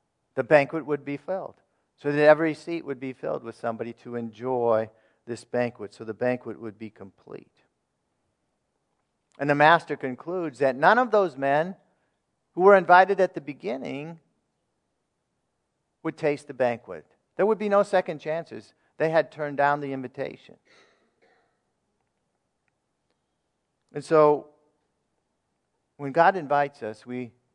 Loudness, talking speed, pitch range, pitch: -24 LUFS, 135 wpm, 125-160 Hz, 145 Hz